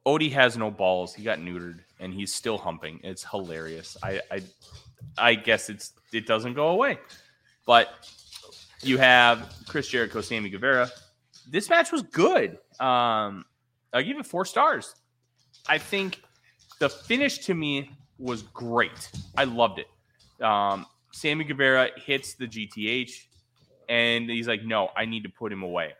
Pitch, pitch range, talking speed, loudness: 120 Hz, 105-135 Hz, 150 wpm, -25 LUFS